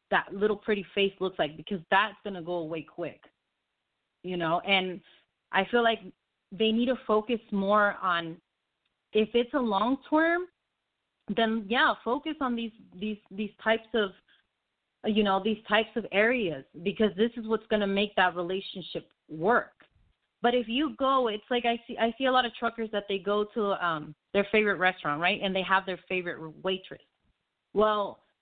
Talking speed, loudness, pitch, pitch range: 180 wpm, -28 LUFS, 210 Hz, 185-230 Hz